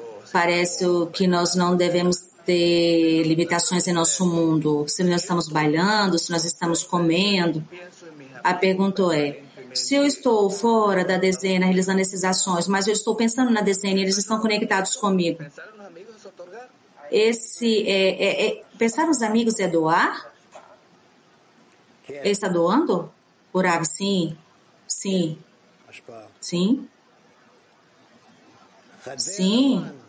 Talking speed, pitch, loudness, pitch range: 115 wpm, 185 Hz, -19 LUFS, 170-210 Hz